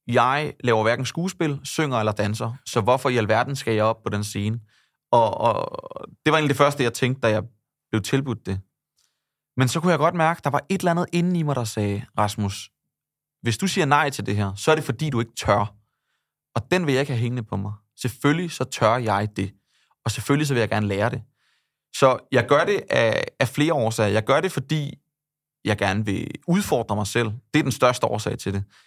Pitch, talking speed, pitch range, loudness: 125 Hz, 230 wpm, 105-150 Hz, -23 LUFS